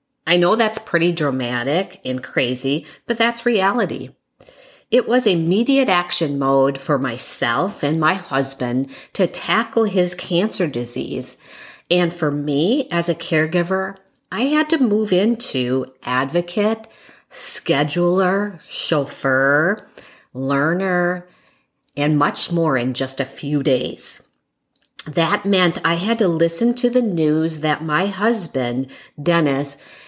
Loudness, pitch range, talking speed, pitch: -19 LUFS, 140-200 Hz, 120 wpm, 170 Hz